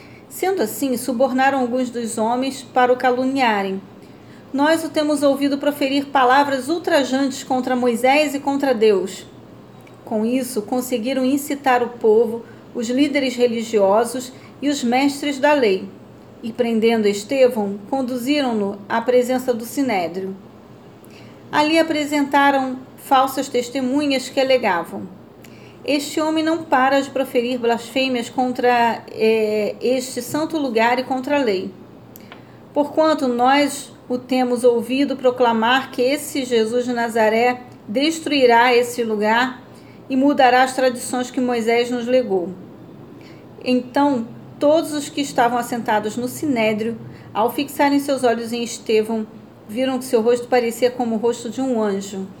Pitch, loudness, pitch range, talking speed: 255 Hz, -19 LUFS, 235-275 Hz, 130 wpm